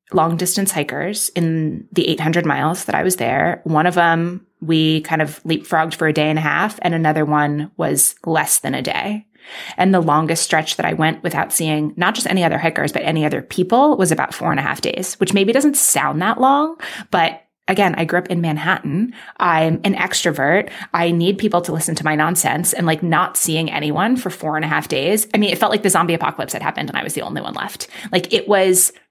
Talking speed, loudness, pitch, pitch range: 230 wpm, -17 LUFS, 170 Hz, 160-195 Hz